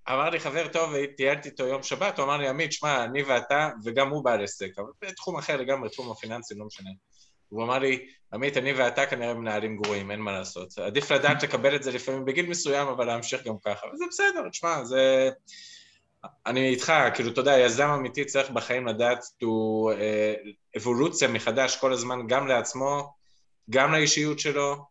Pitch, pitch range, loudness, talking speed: 130 Hz, 115-145 Hz, -26 LUFS, 185 wpm